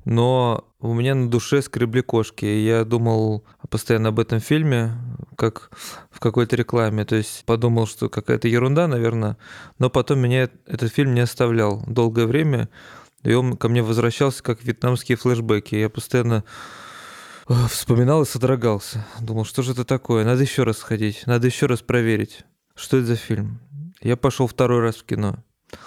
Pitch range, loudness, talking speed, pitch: 115-130 Hz, -21 LUFS, 160 wpm, 120 Hz